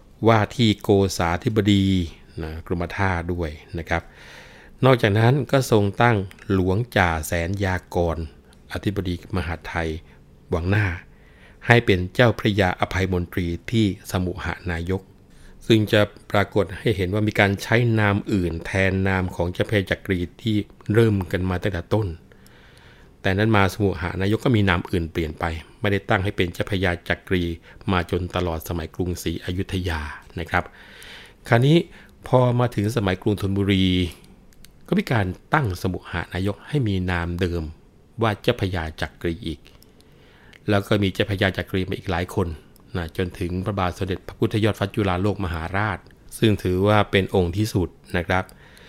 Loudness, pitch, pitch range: -22 LUFS, 95 Hz, 85-105 Hz